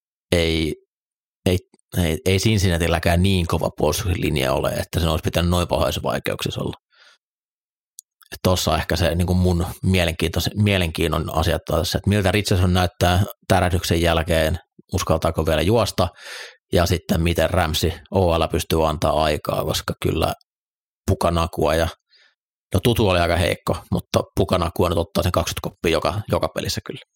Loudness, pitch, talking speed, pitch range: -21 LUFS, 85 Hz, 140 wpm, 80-95 Hz